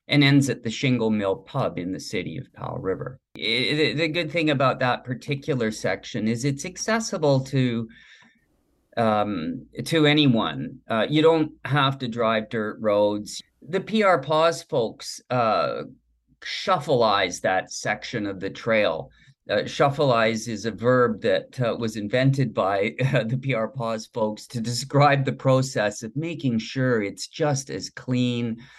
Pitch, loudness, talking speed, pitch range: 125 Hz, -24 LUFS, 155 wpm, 110-145 Hz